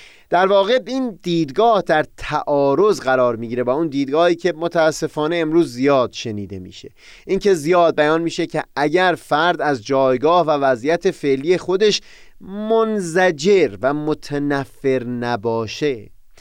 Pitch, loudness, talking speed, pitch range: 160 Hz, -18 LUFS, 130 wpm, 135-185 Hz